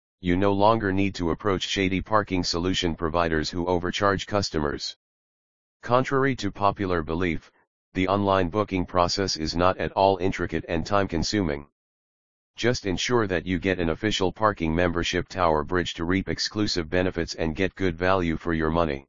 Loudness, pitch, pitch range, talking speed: -25 LUFS, 90 Hz, 85-100 Hz, 160 wpm